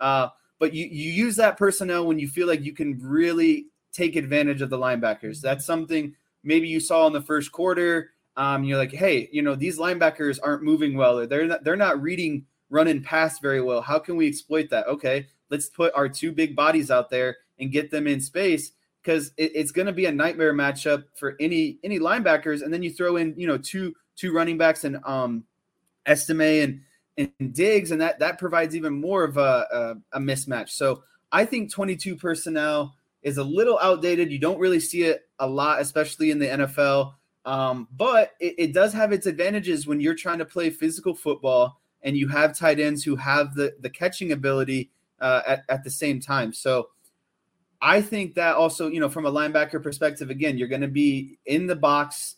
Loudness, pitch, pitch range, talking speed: -23 LUFS, 155 Hz, 140-170 Hz, 205 wpm